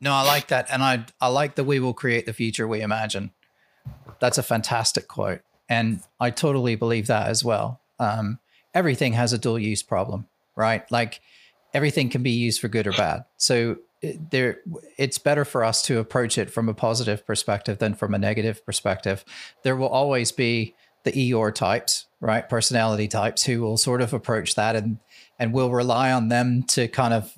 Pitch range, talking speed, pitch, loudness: 110-130 Hz, 195 wpm, 120 Hz, -23 LUFS